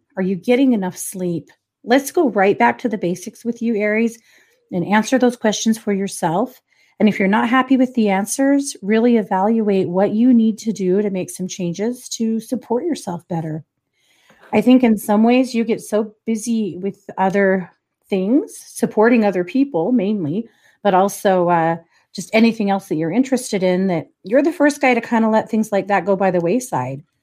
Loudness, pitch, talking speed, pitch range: -18 LUFS, 215 Hz, 190 wpm, 190-235 Hz